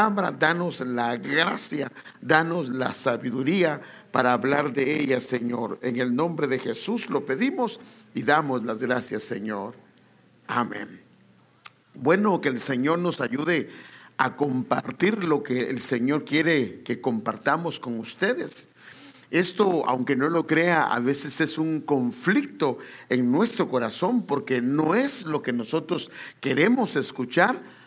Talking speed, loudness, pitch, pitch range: 135 wpm, -25 LUFS, 145 Hz, 125-175 Hz